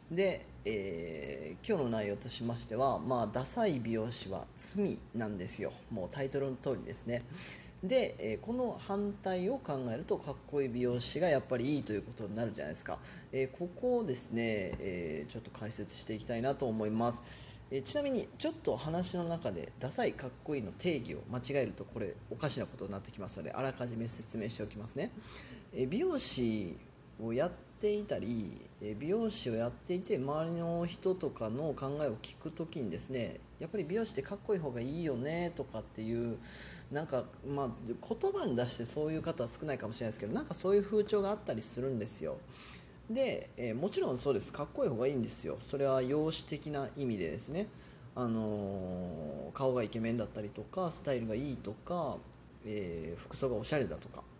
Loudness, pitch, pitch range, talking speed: -37 LUFS, 130 Hz, 115-170 Hz, 395 characters per minute